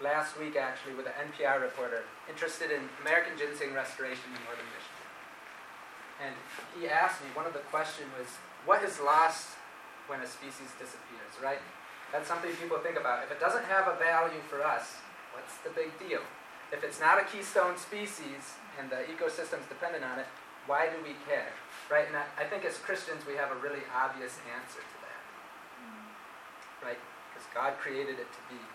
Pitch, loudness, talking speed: 170 Hz, -33 LUFS, 180 wpm